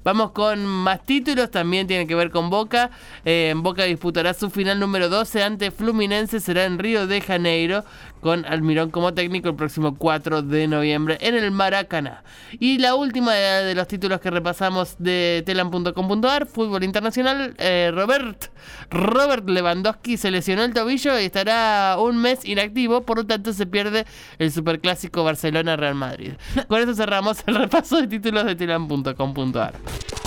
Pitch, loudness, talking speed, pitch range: 195 Hz, -21 LUFS, 155 wpm, 170-225 Hz